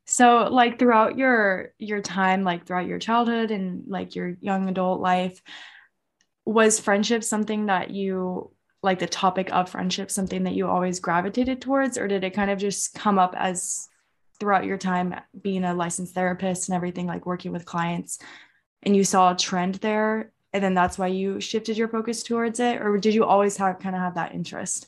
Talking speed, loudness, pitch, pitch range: 195 wpm, -24 LUFS, 195 Hz, 180-220 Hz